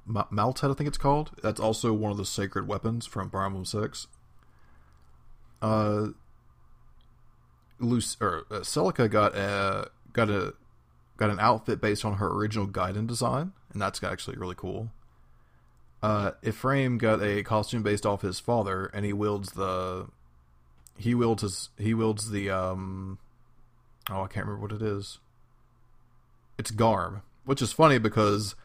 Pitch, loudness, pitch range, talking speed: 105 Hz, -28 LUFS, 95-115 Hz, 150 wpm